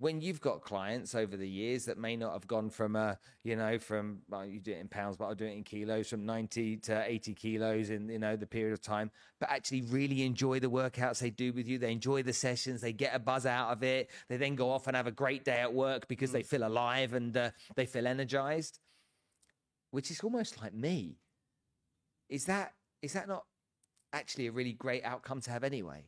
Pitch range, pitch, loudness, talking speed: 110-130 Hz, 120 Hz, -36 LUFS, 230 wpm